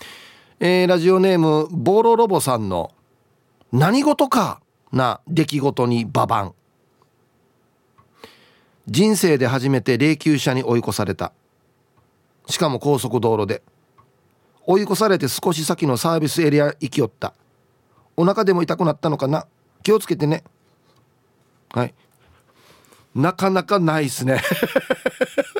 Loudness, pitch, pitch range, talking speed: -19 LUFS, 150 Hz, 125-185 Hz, 235 characters per minute